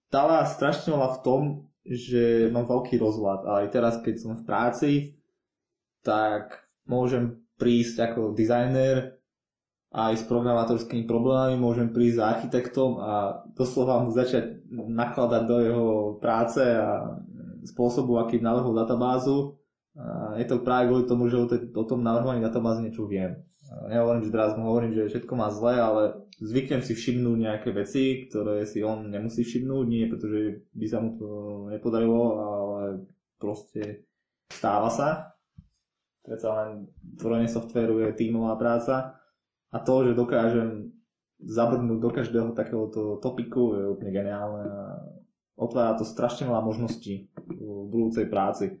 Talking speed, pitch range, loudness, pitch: 140 wpm, 110-125 Hz, -26 LUFS, 115 Hz